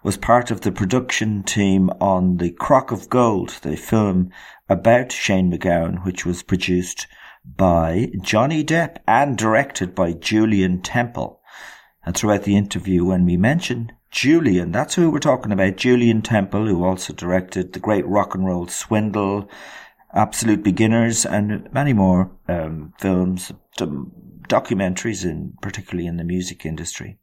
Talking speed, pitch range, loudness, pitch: 145 wpm, 90-110 Hz, -19 LUFS, 95 Hz